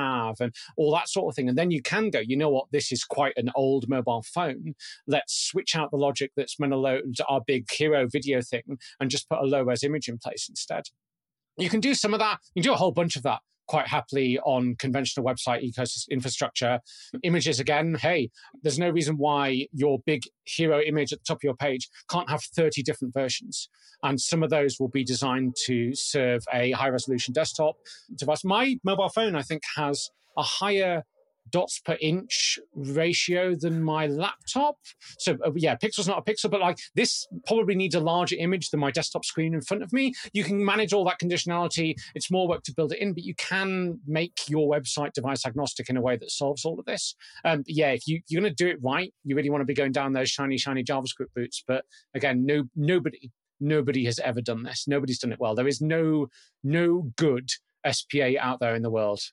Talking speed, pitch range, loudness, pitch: 220 wpm, 130-170 Hz, -27 LUFS, 150 Hz